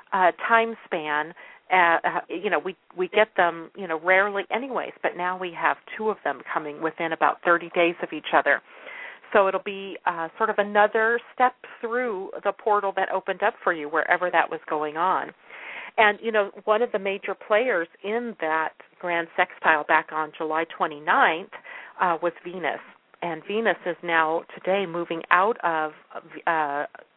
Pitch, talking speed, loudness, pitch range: 180 Hz, 170 wpm, -24 LUFS, 165-210 Hz